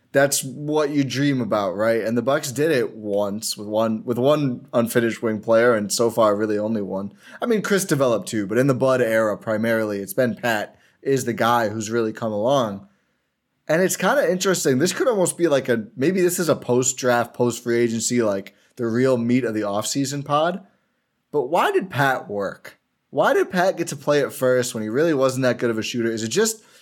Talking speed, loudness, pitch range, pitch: 220 wpm, -21 LUFS, 110-145 Hz, 120 Hz